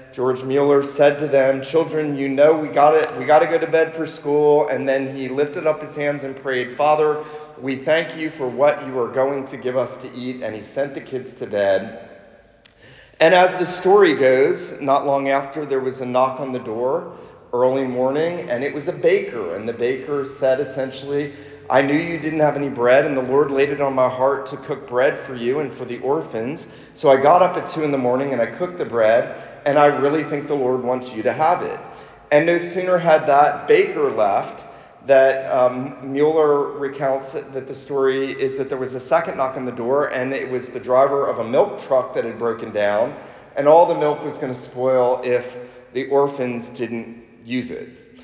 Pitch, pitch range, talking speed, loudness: 140 Hz, 130-150 Hz, 220 wpm, -19 LUFS